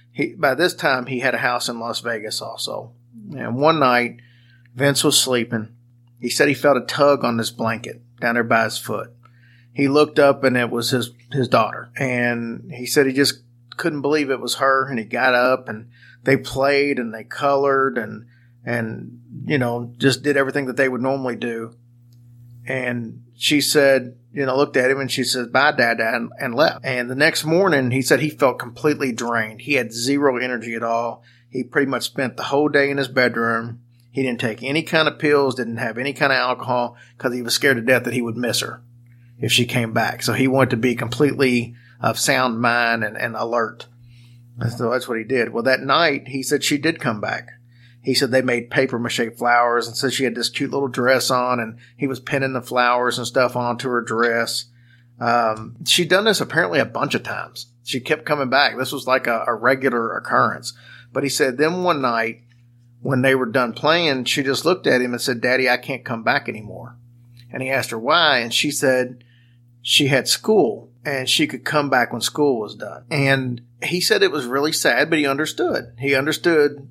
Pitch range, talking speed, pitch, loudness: 120-135 Hz, 215 wpm, 125 Hz, -19 LUFS